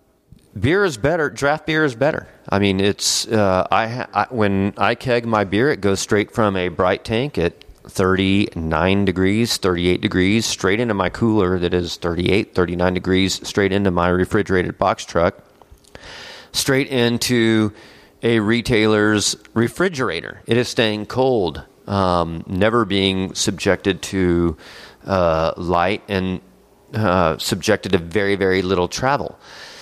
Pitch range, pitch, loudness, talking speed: 95-110 Hz, 100 Hz, -19 LUFS, 145 wpm